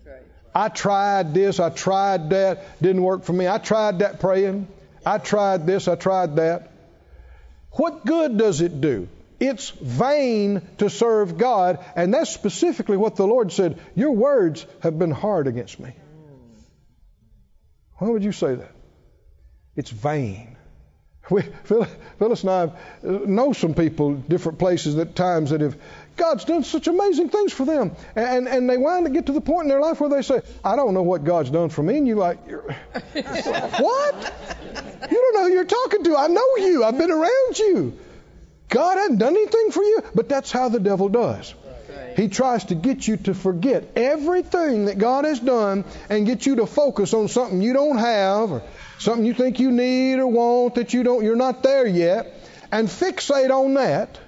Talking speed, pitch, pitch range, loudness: 185 wpm, 210 Hz, 180-270 Hz, -21 LUFS